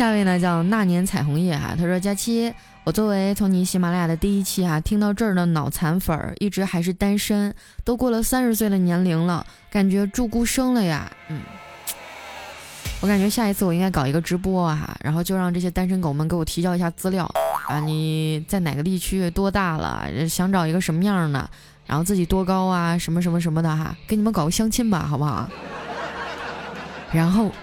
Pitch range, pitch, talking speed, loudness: 165-200 Hz, 180 Hz, 315 characters per minute, -22 LUFS